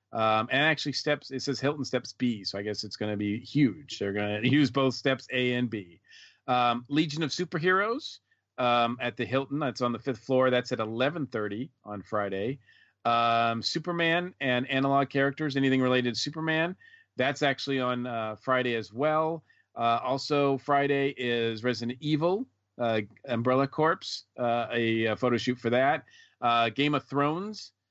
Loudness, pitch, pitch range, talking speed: -28 LUFS, 130 Hz, 115-145 Hz, 170 wpm